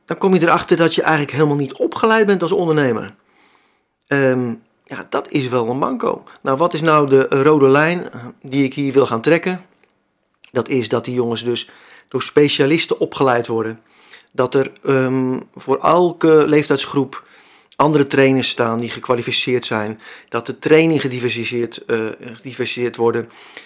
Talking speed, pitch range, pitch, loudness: 155 wpm, 120-150 Hz, 135 Hz, -17 LUFS